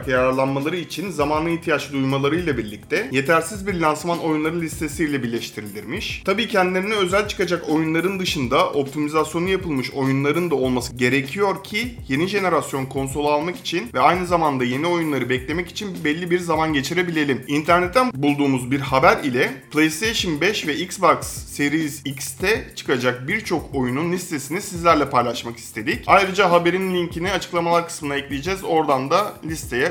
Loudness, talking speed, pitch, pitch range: -21 LUFS, 140 wpm, 155 Hz, 135-175 Hz